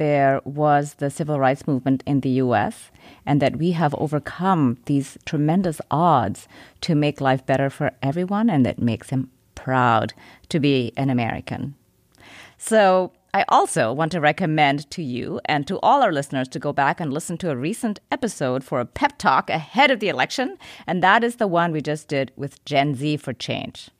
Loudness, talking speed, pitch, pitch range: -21 LUFS, 190 wpm, 145 Hz, 130-165 Hz